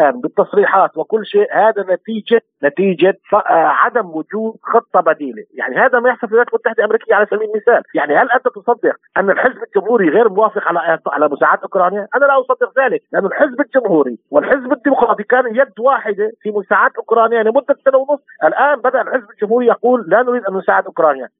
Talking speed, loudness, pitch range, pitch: 175 wpm, -14 LUFS, 205-255 Hz, 225 Hz